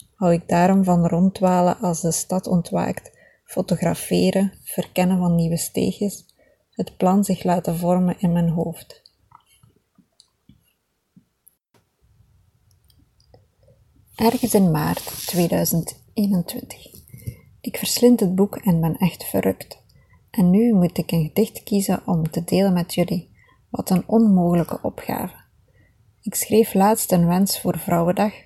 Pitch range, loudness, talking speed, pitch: 160-195 Hz, -20 LUFS, 120 wpm, 175 Hz